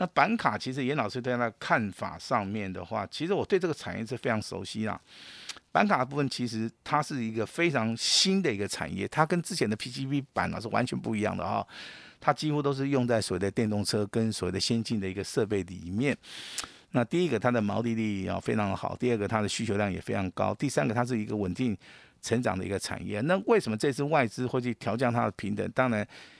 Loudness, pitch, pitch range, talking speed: -29 LUFS, 115 Hz, 105-135 Hz, 350 characters per minute